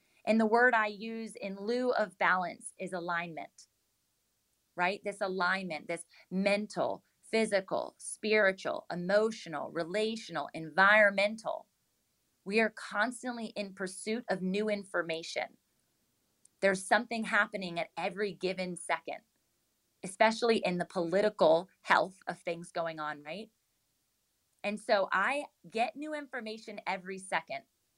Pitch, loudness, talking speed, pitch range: 200 Hz, -32 LUFS, 115 wpm, 180-220 Hz